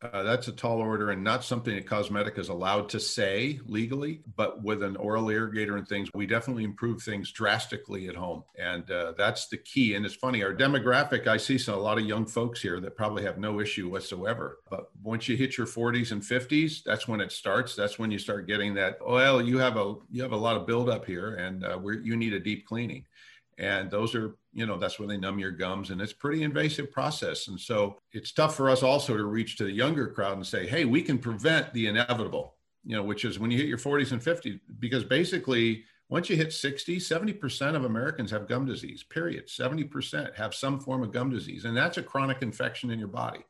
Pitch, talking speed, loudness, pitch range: 115 Hz, 230 wpm, -29 LUFS, 105-130 Hz